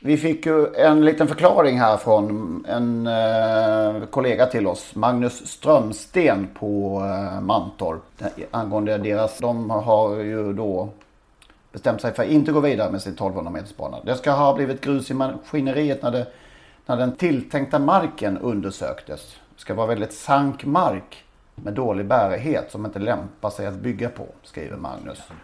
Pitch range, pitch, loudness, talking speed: 105-140 Hz, 115 Hz, -21 LUFS, 150 wpm